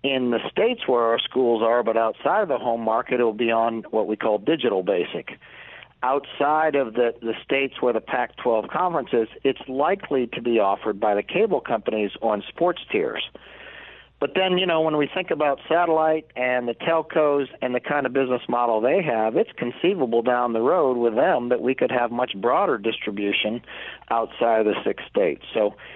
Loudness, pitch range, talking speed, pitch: -23 LUFS, 115-140 Hz, 195 wpm, 125 Hz